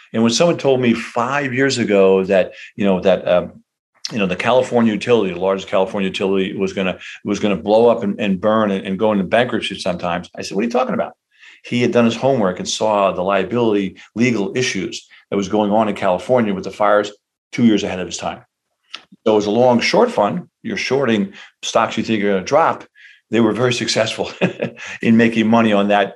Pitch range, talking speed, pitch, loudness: 100-120 Hz, 215 wpm, 110 Hz, -17 LUFS